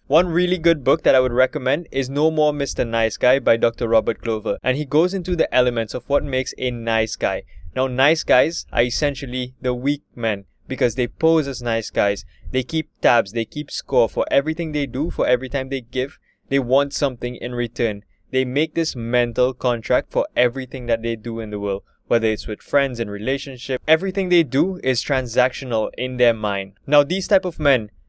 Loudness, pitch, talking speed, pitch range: -21 LUFS, 130 Hz, 205 wpm, 115-145 Hz